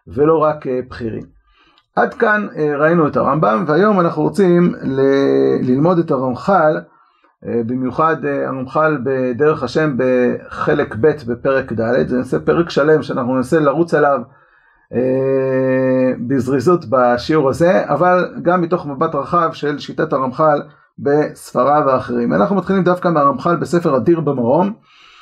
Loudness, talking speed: -15 LUFS, 120 wpm